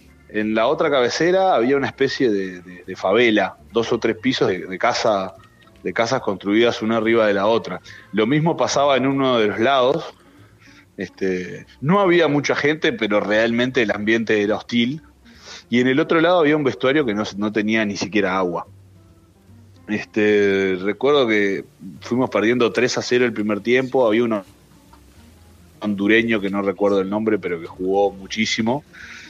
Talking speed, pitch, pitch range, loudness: 170 wpm, 110 Hz, 100-125 Hz, -19 LUFS